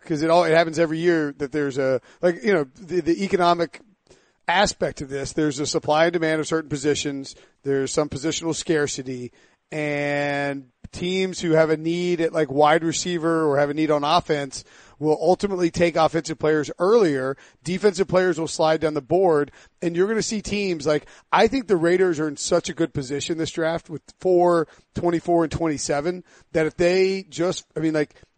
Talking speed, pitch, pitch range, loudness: 190 wpm, 160 Hz, 150-175 Hz, -22 LUFS